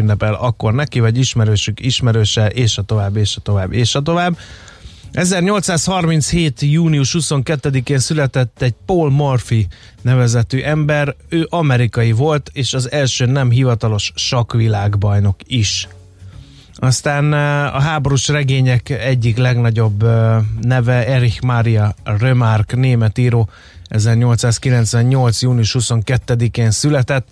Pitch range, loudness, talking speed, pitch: 110-140 Hz, -15 LUFS, 110 wpm, 125 Hz